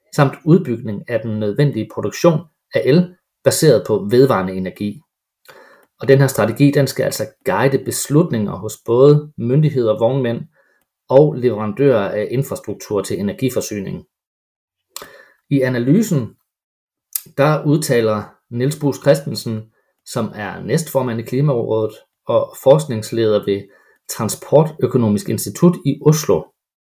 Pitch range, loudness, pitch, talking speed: 110-145 Hz, -17 LUFS, 130 Hz, 110 wpm